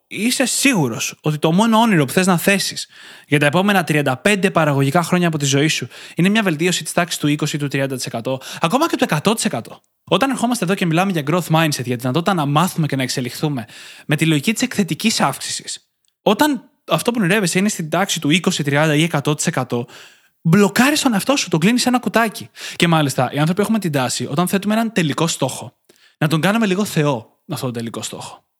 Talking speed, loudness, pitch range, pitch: 205 wpm, -17 LUFS, 145-205 Hz, 170 Hz